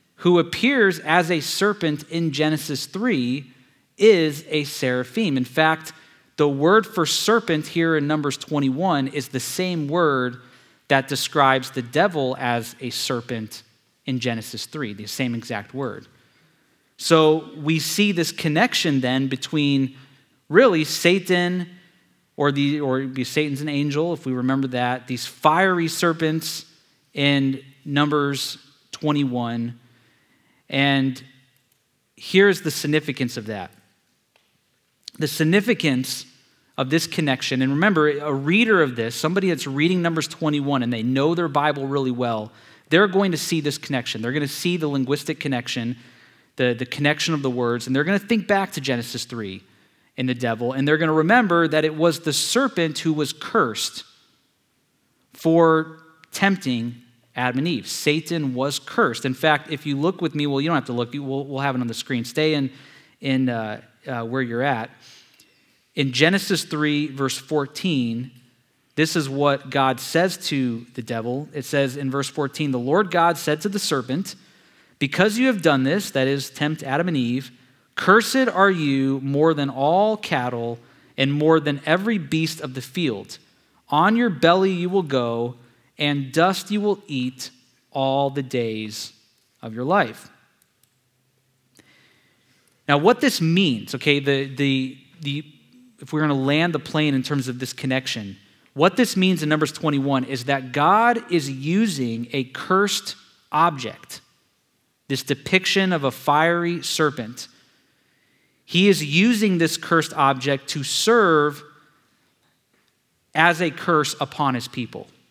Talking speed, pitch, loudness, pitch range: 155 wpm, 145 Hz, -21 LUFS, 130-165 Hz